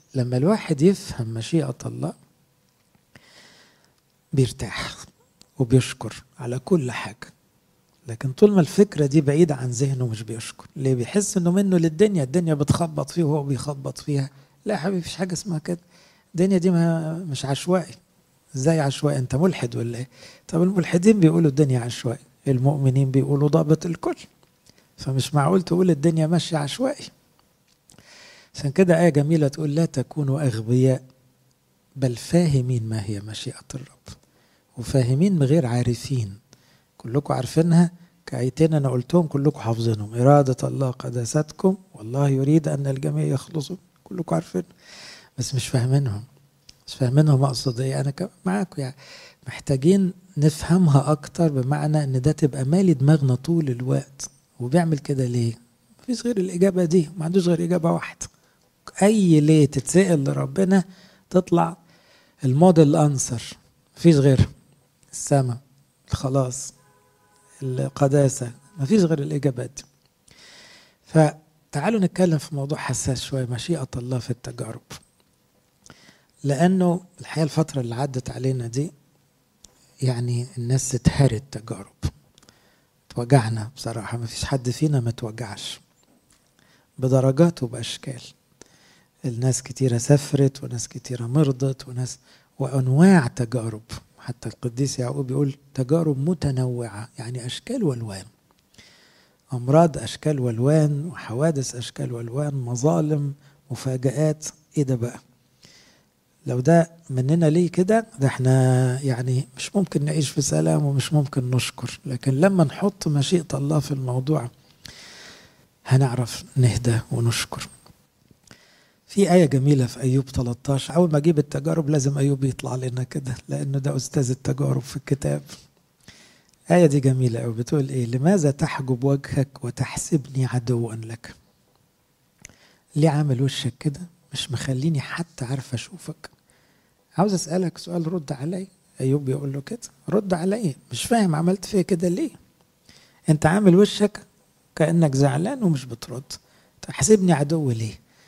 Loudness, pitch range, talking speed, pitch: -22 LUFS, 130-165 Hz, 120 wpm, 140 Hz